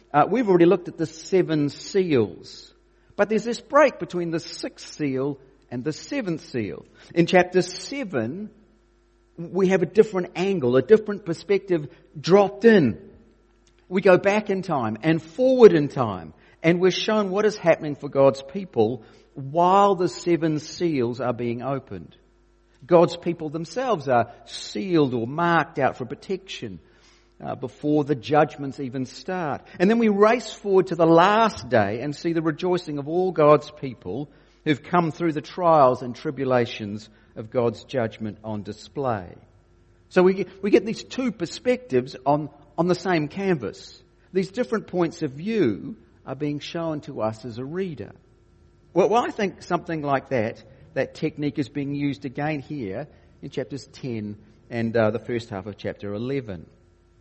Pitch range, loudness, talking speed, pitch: 125-185 Hz, -23 LUFS, 160 wpm, 155 Hz